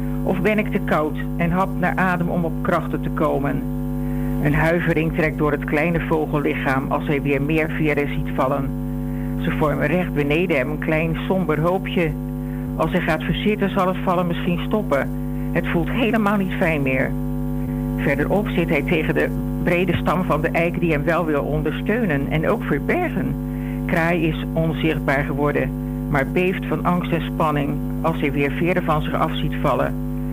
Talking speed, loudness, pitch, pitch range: 175 wpm, -21 LUFS, 140 Hz, 130-155 Hz